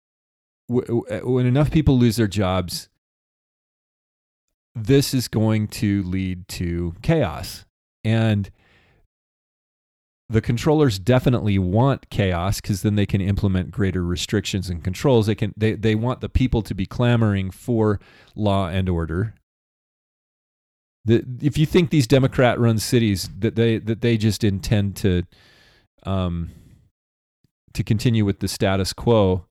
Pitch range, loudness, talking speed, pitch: 95-120 Hz, -21 LUFS, 130 wpm, 105 Hz